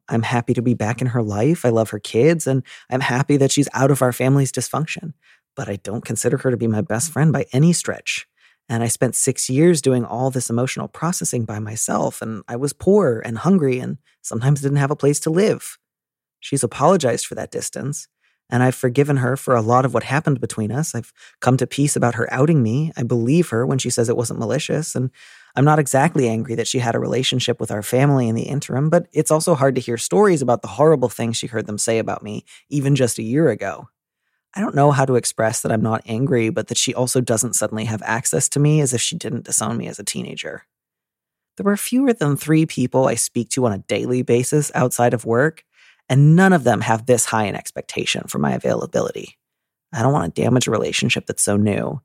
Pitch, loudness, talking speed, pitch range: 130 Hz, -19 LUFS, 230 wpm, 115-145 Hz